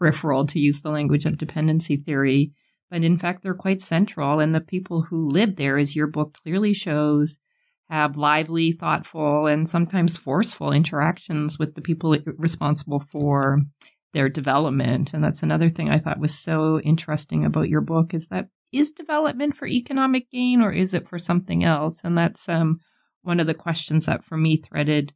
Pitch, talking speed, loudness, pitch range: 160 Hz, 180 wpm, -22 LUFS, 150-175 Hz